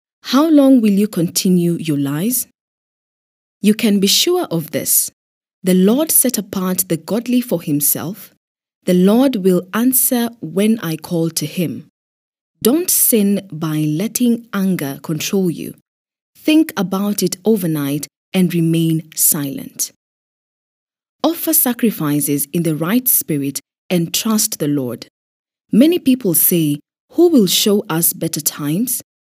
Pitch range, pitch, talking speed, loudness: 160-230 Hz, 185 Hz, 130 wpm, -15 LUFS